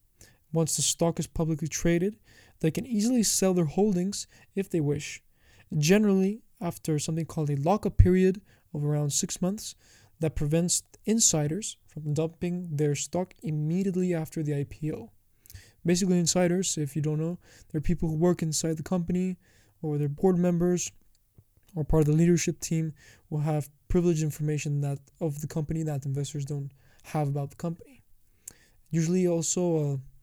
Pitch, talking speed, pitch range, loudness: 160 Hz, 150 wpm, 145-180 Hz, -28 LUFS